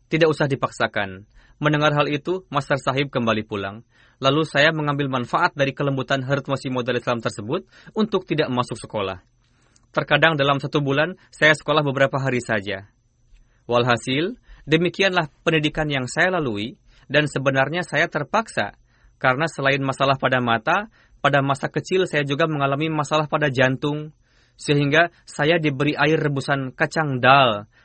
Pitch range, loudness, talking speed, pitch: 125-155 Hz, -21 LUFS, 140 wpm, 140 Hz